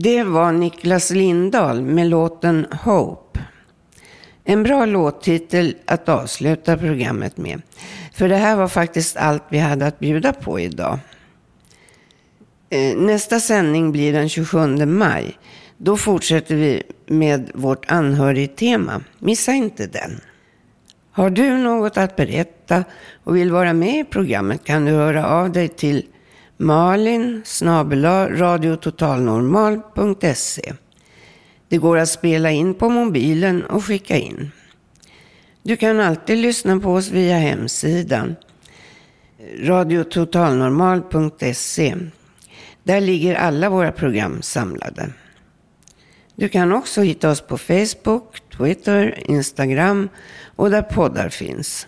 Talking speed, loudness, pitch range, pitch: 115 wpm, -18 LUFS, 155-195 Hz, 170 Hz